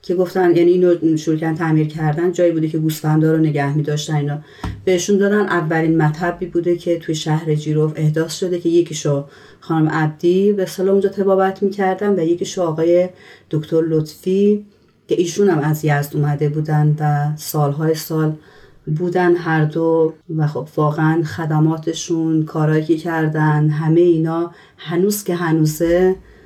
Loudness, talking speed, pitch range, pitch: -17 LUFS, 145 wpm, 155-175 Hz, 160 Hz